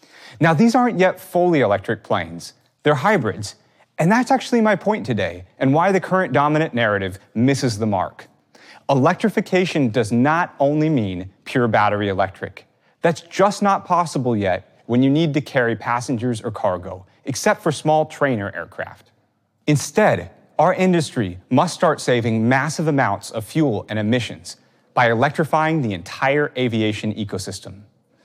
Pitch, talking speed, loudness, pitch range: 130 Hz, 145 wpm, -19 LUFS, 105-165 Hz